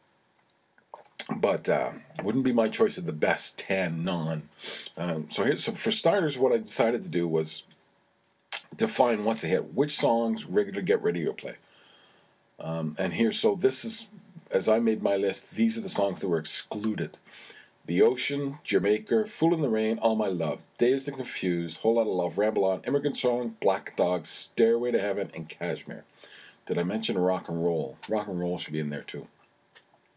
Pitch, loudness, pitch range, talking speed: 110 Hz, -27 LUFS, 85-130 Hz, 185 wpm